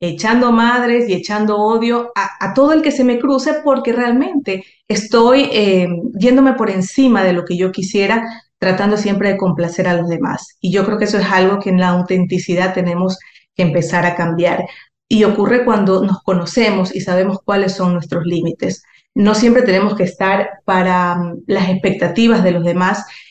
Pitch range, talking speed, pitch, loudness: 180-230 Hz, 180 wpm, 195 Hz, -14 LUFS